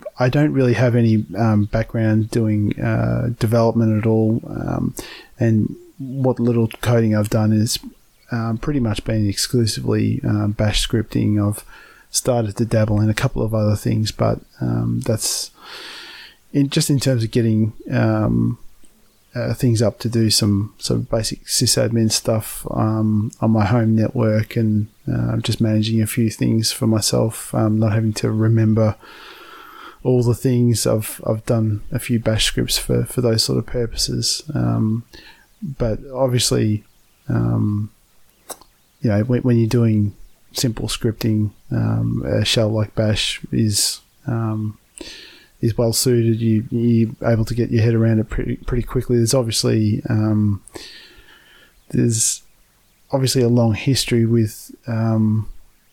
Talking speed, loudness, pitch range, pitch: 145 wpm, -19 LUFS, 110-120 Hz, 110 Hz